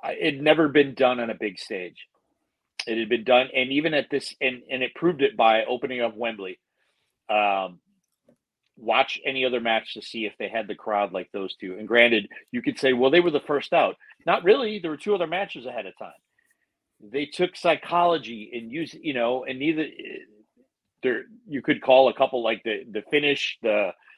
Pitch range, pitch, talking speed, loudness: 115-165 Hz, 130 Hz, 205 wpm, -24 LUFS